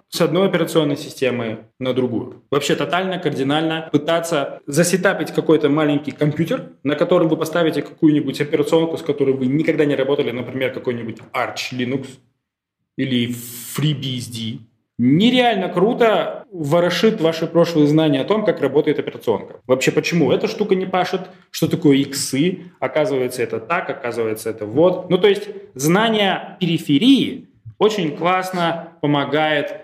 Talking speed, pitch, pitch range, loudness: 135 wpm, 155 Hz, 135-175 Hz, -19 LUFS